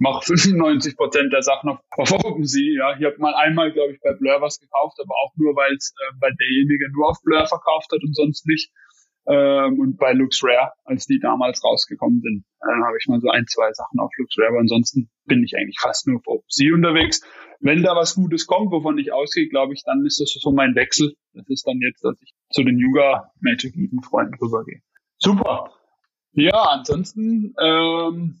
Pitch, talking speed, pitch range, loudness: 155 Hz, 205 wpm, 140-210 Hz, -19 LUFS